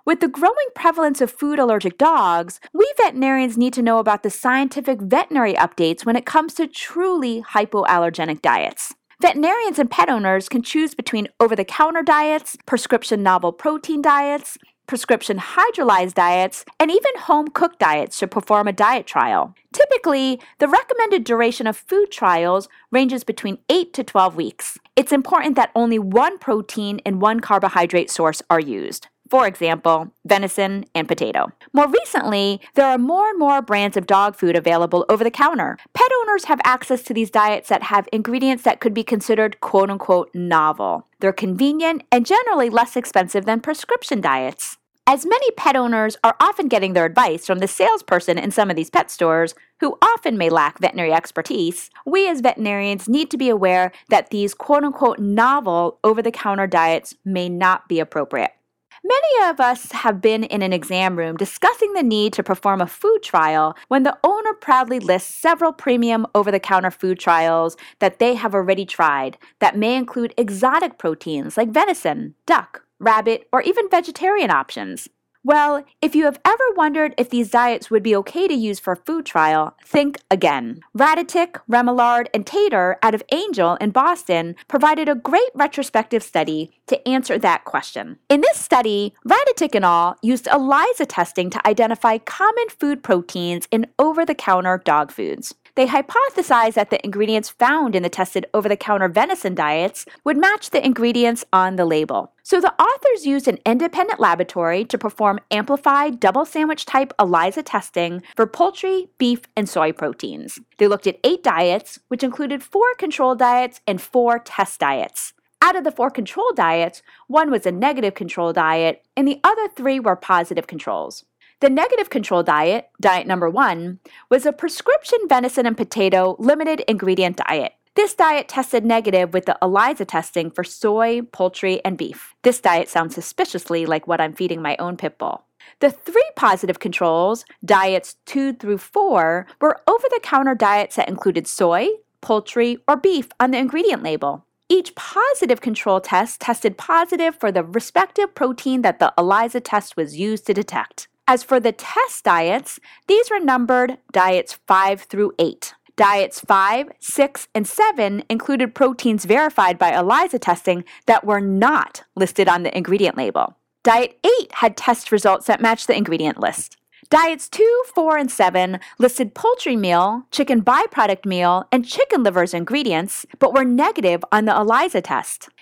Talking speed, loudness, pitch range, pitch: 170 wpm, -18 LUFS, 190-290 Hz, 235 Hz